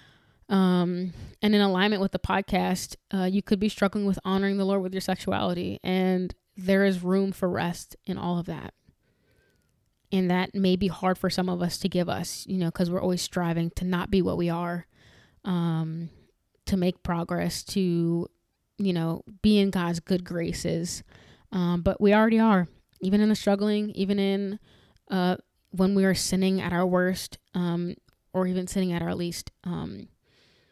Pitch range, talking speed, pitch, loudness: 175-195 Hz, 180 wpm, 185 Hz, -26 LUFS